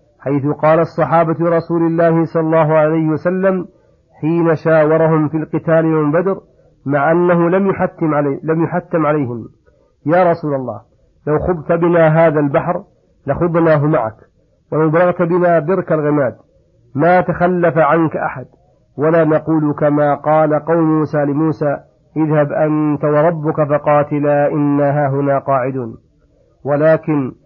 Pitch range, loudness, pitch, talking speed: 145-165 Hz, -14 LUFS, 155 Hz, 125 wpm